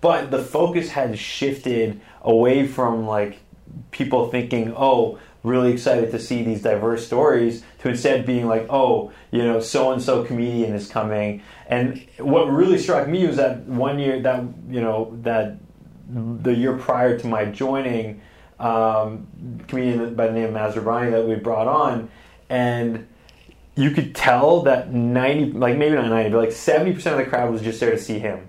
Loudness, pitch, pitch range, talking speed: -21 LUFS, 120 Hz, 115-130 Hz, 175 wpm